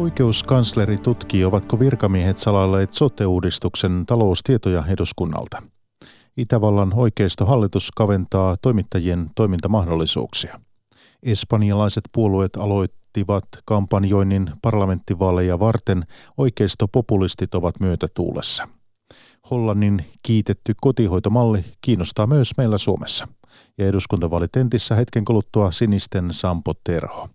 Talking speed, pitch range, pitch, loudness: 80 wpm, 95-115 Hz, 105 Hz, -20 LUFS